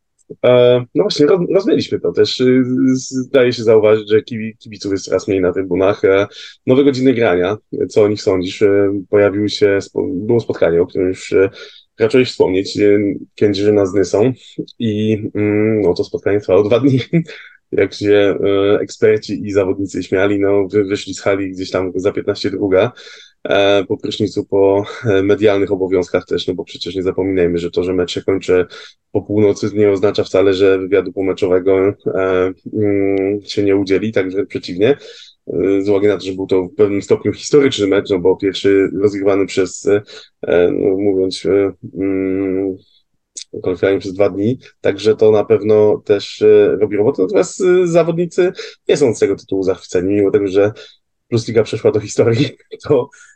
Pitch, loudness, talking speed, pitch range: 105 Hz, -15 LUFS, 155 wpm, 95-130 Hz